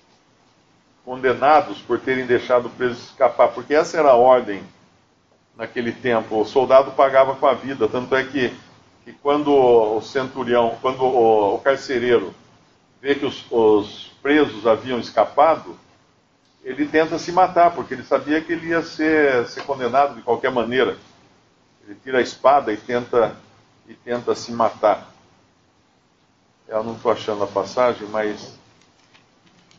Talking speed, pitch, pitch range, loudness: 140 wpm, 125 Hz, 110-140 Hz, -19 LUFS